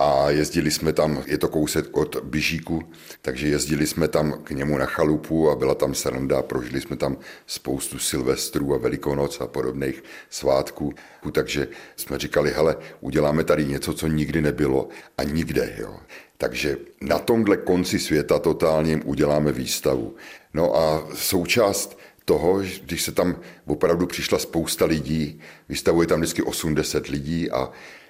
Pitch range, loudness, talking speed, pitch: 70-80 Hz, -23 LUFS, 150 wpm, 75 Hz